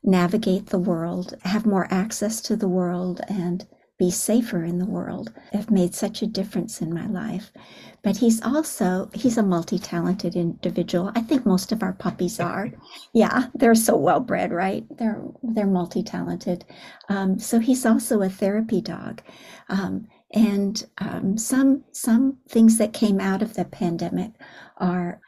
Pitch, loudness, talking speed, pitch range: 200 Hz, -23 LUFS, 155 wpm, 180-225 Hz